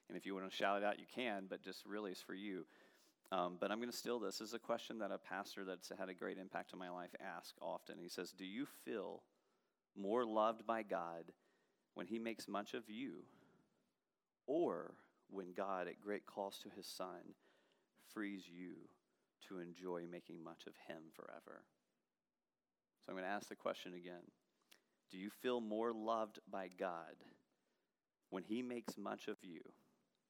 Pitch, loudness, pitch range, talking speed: 100 Hz, -47 LUFS, 90-115 Hz, 185 wpm